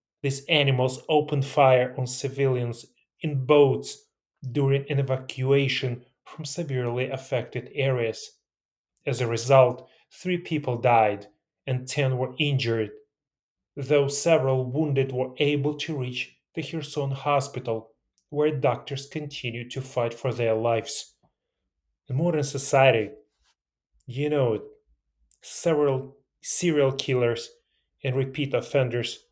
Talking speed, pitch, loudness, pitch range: 110 wpm, 135 Hz, -25 LUFS, 125-145 Hz